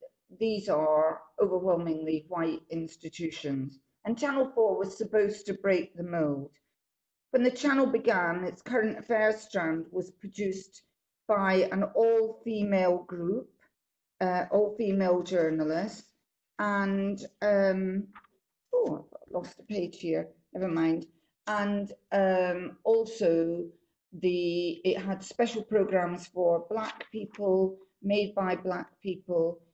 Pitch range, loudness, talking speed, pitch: 175-210 Hz, -30 LUFS, 115 wpm, 190 Hz